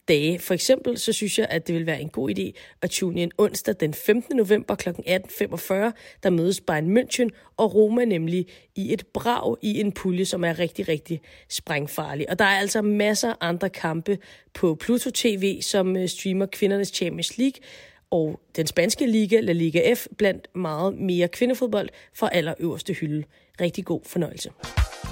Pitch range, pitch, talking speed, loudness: 170-215 Hz, 190 Hz, 170 wpm, -24 LUFS